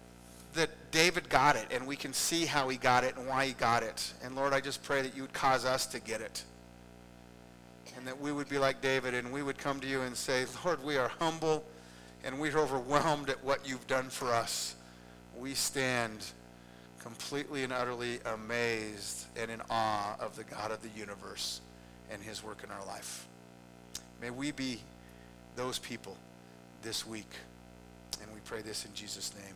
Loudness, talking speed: -34 LUFS, 190 wpm